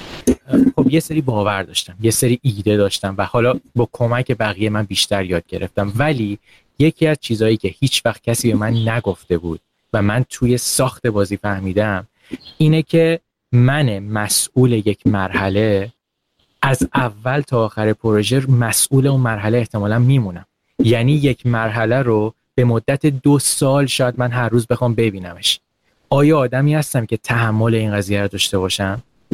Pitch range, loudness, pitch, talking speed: 105-130 Hz, -17 LUFS, 115 Hz, 155 wpm